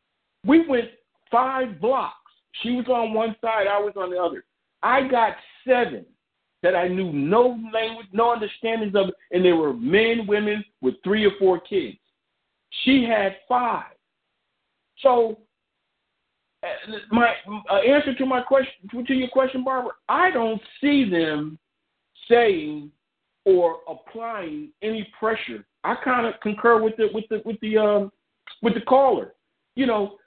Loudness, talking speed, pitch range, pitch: -22 LUFS, 150 wpm, 205-250 Hz, 225 Hz